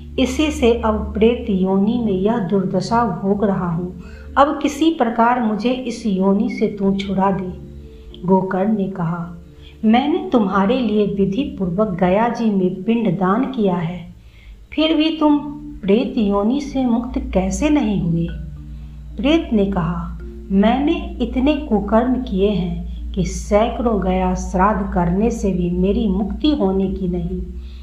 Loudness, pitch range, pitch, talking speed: -18 LUFS, 185-240 Hz, 205 Hz, 140 wpm